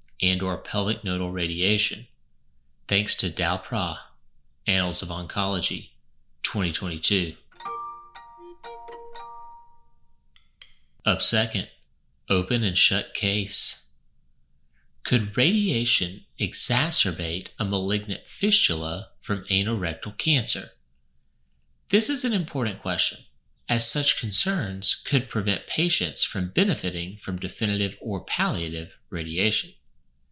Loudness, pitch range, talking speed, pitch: -23 LUFS, 80-120 Hz, 85 wpm, 95 Hz